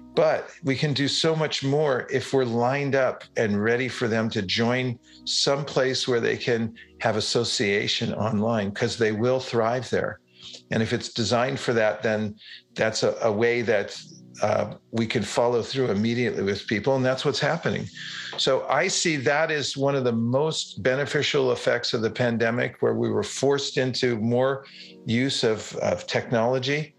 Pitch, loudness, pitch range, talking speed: 125 Hz, -24 LUFS, 115-135 Hz, 175 wpm